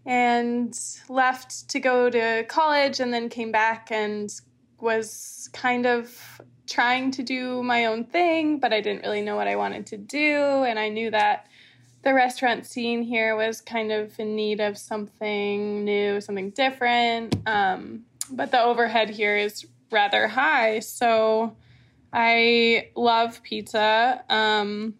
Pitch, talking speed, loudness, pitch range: 225 Hz, 145 wpm, -23 LUFS, 210-245 Hz